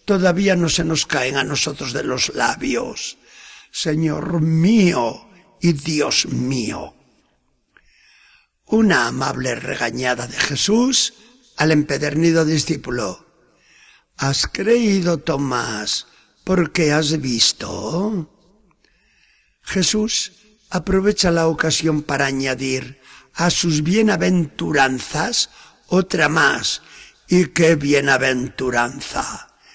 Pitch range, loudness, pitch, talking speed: 140-190 Hz, -18 LUFS, 160 Hz, 85 wpm